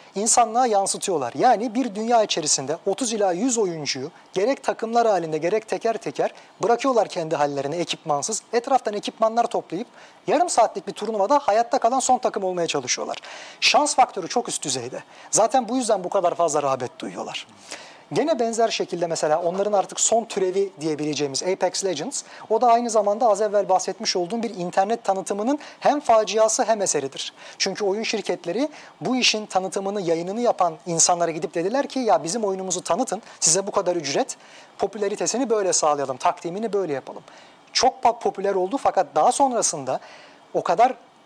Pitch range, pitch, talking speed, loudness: 180-230 Hz, 200 Hz, 155 wpm, -22 LUFS